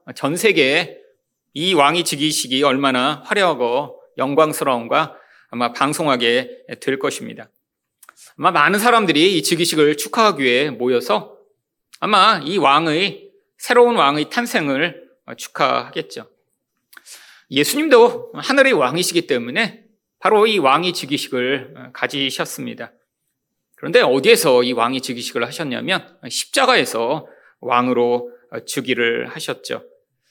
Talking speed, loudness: 270 characters per minute, -17 LUFS